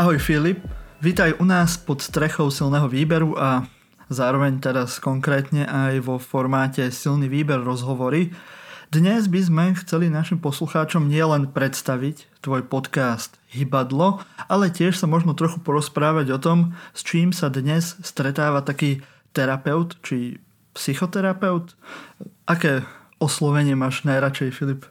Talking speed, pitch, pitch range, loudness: 125 wpm, 150 Hz, 135-170 Hz, -21 LUFS